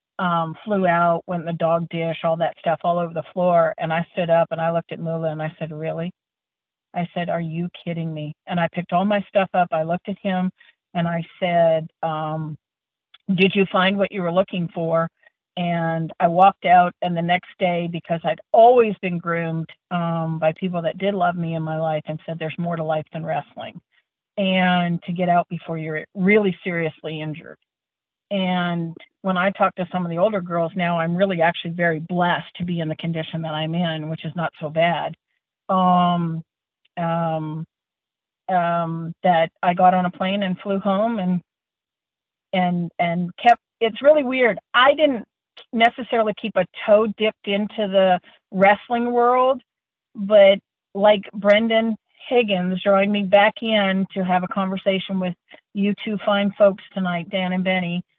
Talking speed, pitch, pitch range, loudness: 185 wpm, 175 Hz, 165-195 Hz, -21 LUFS